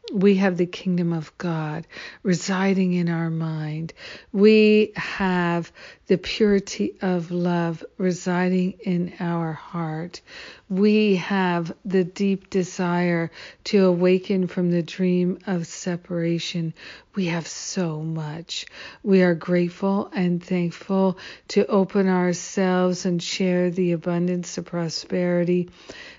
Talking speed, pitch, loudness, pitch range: 115 wpm, 180 Hz, -23 LUFS, 170-190 Hz